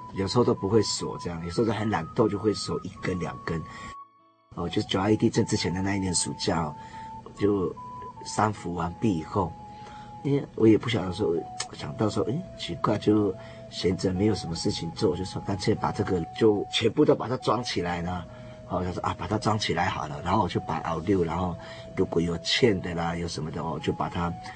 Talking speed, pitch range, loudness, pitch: 300 characters per minute, 90-110 Hz, -27 LUFS, 105 Hz